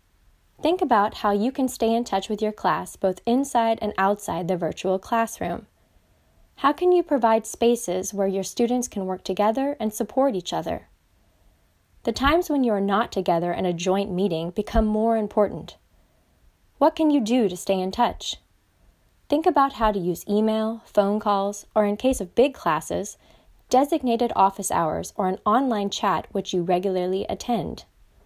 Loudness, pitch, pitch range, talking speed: -23 LUFS, 210 Hz, 190-240 Hz, 170 wpm